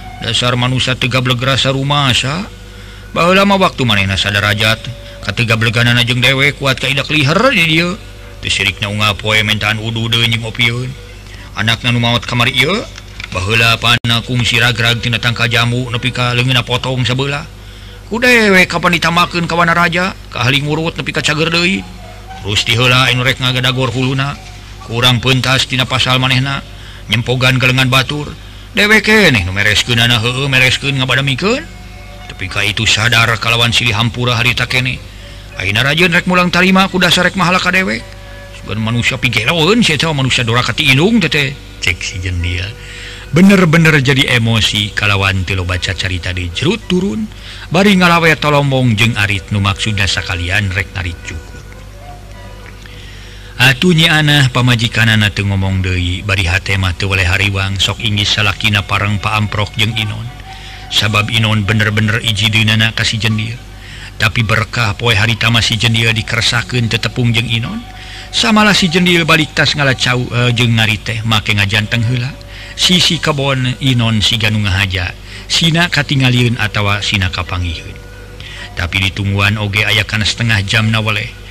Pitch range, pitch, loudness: 100-130 Hz, 115 Hz, -12 LUFS